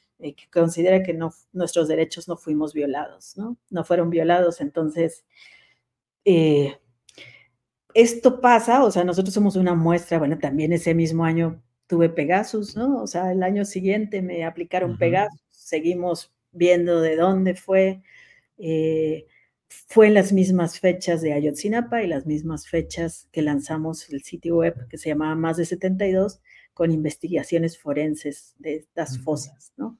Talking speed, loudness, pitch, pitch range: 150 wpm, -22 LUFS, 170 Hz, 155-185 Hz